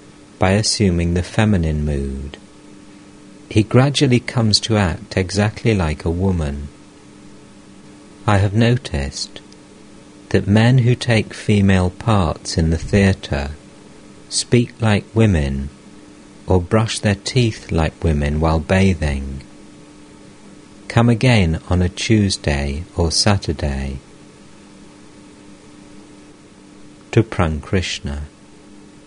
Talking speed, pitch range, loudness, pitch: 95 wpm, 85-105 Hz, -18 LUFS, 100 Hz